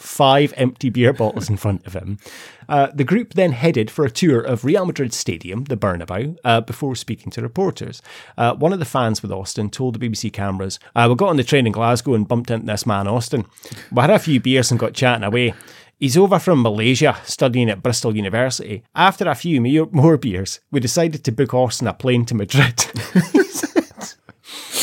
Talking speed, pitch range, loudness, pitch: 200 wpm, 115-145 Hz, -18 LUFS, 125 Hz